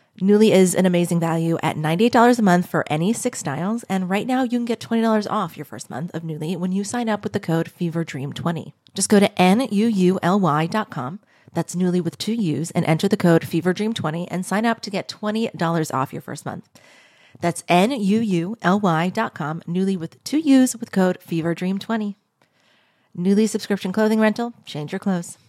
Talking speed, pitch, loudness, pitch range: 175 wpm, 185 Hz, -21 LUFS, 165-215 Hz